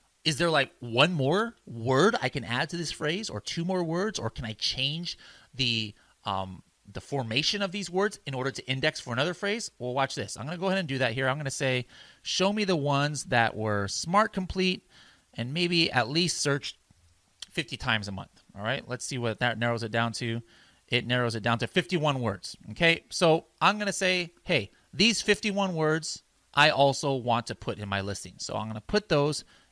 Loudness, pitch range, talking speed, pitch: -28 LUFS, 115-175 Hz, 220 wpm, 135 Hz